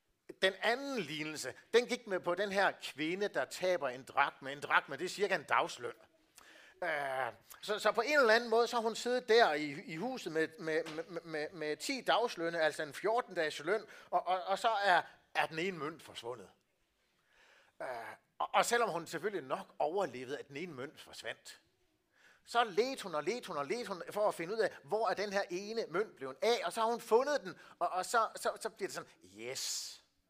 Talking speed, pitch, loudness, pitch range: 220 wpm, 190 Hz, -35 LUFS, 160-230 Hz